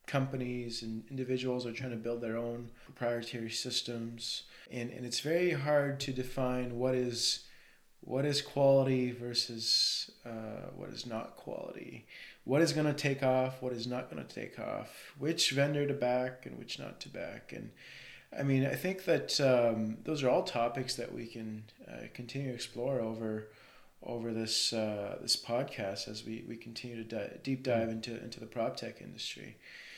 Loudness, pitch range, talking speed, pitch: -34 LUFS, 115-135 Hz, 180 wpm, 125 Hz